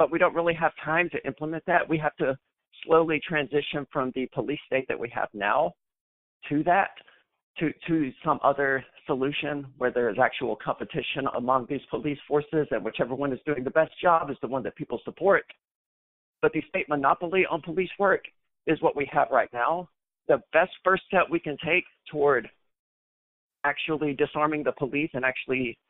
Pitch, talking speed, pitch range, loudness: 150 Hz, 185 wpm, 135-160 Hz, -26 LUFS